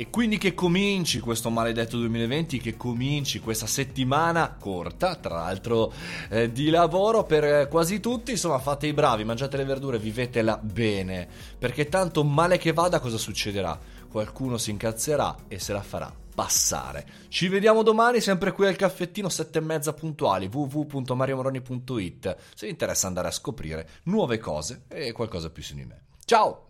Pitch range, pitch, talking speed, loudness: 110-165 Hz, 130 Hz, 160 wpm, -26 LUFS